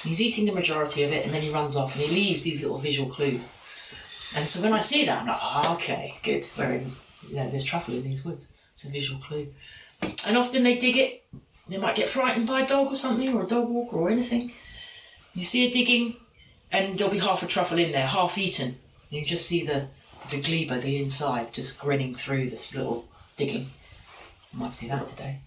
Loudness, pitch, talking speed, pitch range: -26 LUFS, 160 Hz, 225 wpm, 140-230 Hz